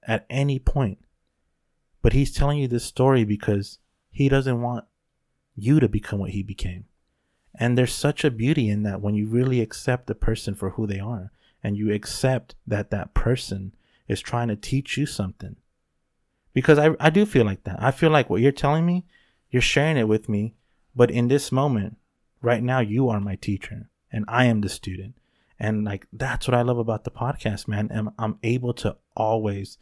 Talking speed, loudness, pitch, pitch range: 195 wpm, -23 LUFS, 115 Hz, 105-130 Hz